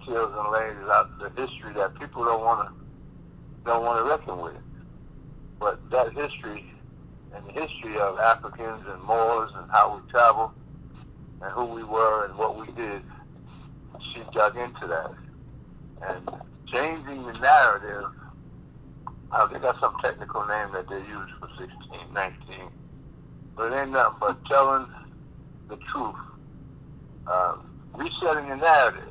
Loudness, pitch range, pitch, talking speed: -25 LUFS, 105-125 Hz, 115 Hz, 140 wpm